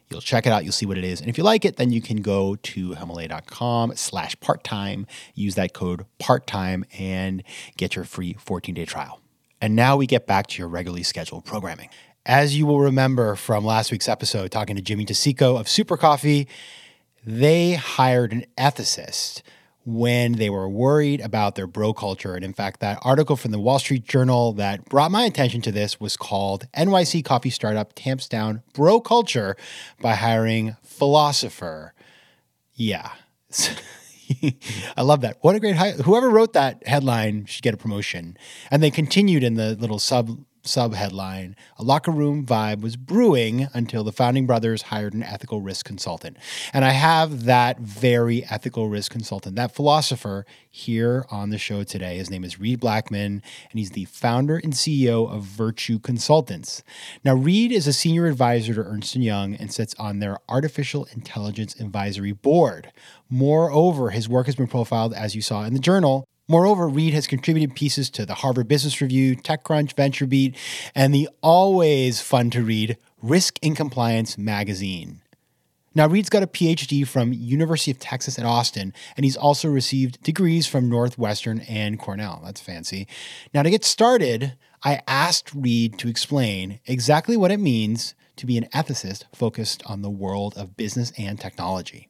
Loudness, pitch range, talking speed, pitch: -21 LUFS, 105-140 Hz, 170 wpm, 120 Hz